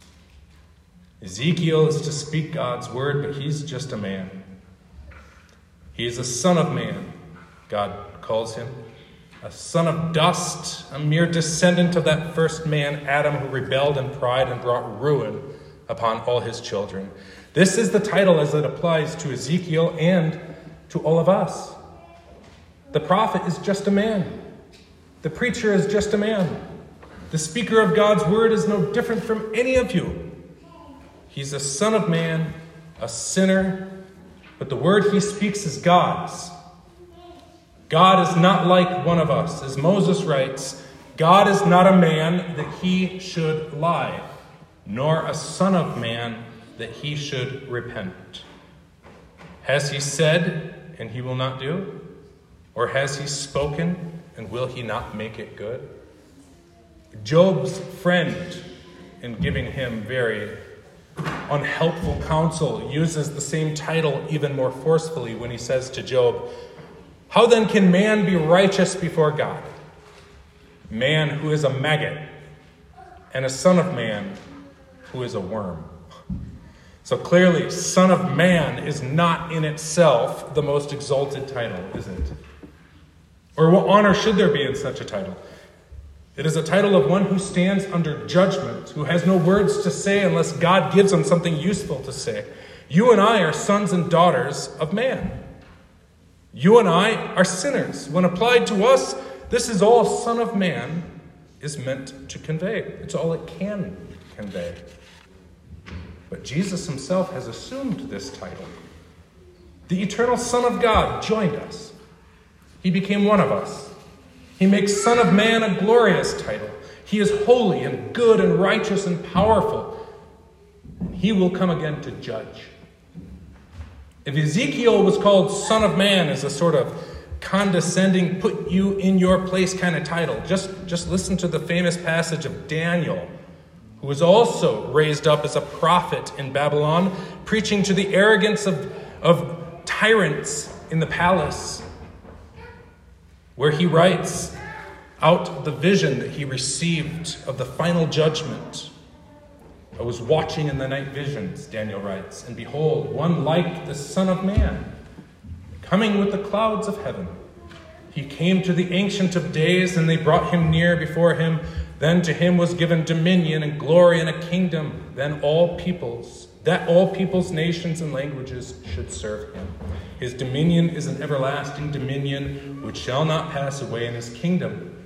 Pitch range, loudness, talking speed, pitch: 130-185 Hz, -21 LUFS, 155 wpm, 160 Hz